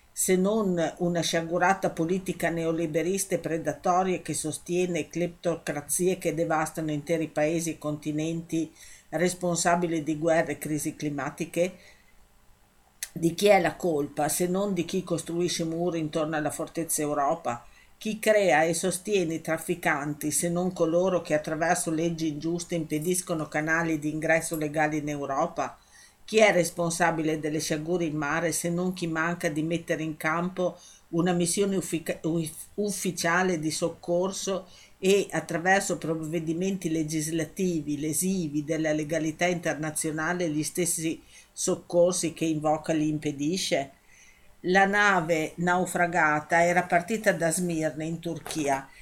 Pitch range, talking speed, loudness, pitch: 155-175 Hz, 125 wpm, -27 LUFS, 165 Hz